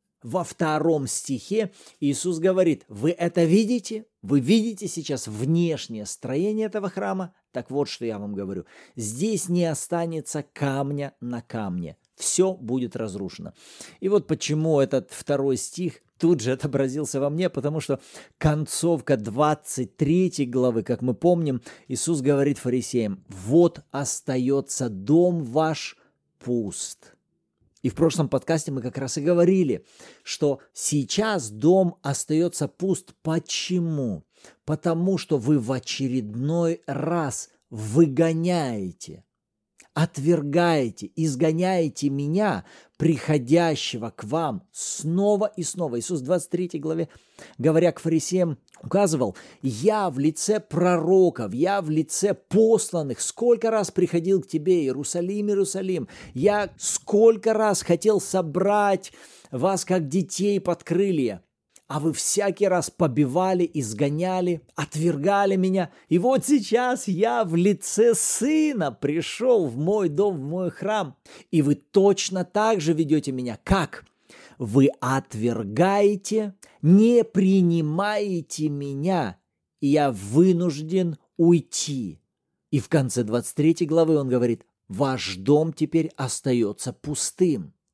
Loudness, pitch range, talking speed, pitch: -24 LUFS, 140-185 Hz, 115 wpm, 160 Hz